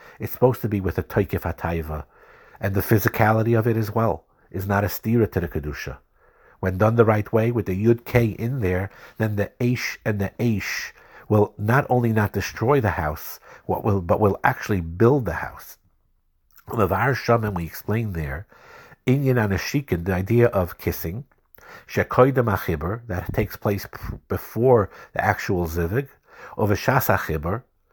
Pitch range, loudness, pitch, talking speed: 95-115 Hz, -23 LUFS, 105 Hz, 165 wpm